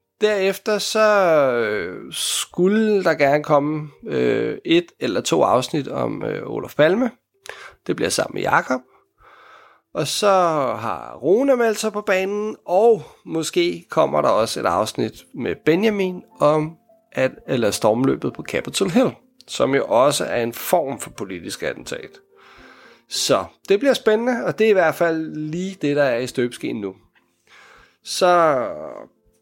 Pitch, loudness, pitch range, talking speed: 210 Hz, -20 LUFS, 160-255 Hz, 140 wpm